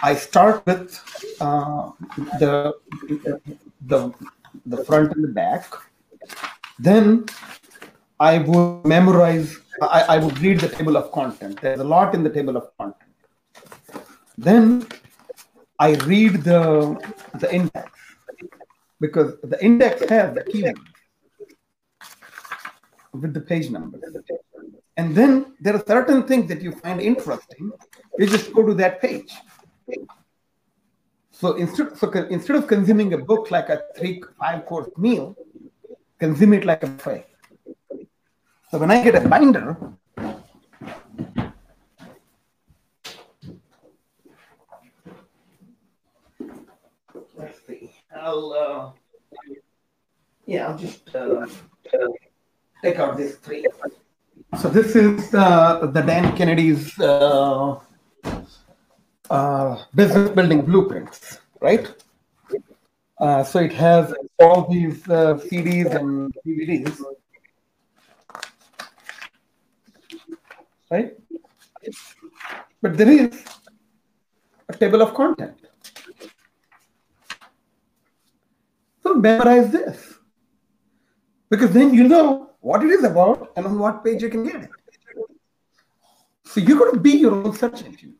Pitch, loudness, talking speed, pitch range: 200 Hz, -18 LUFS, 110 wpm, 160-245 Hz